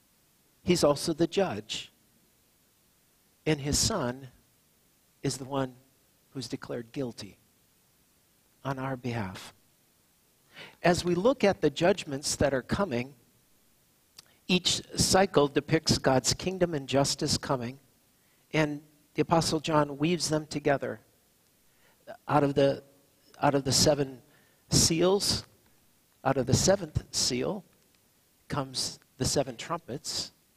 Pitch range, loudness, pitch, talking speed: 130-155 Hz, -28 LUFS, 140 Hz, 110 wpm